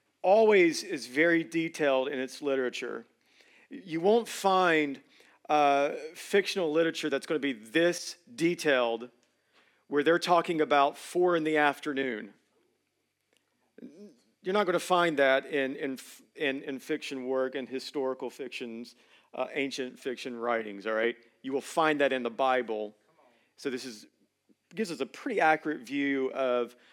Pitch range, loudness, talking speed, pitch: 130-170 Hz, -29 LUFS, 145 wpm, 140 Hz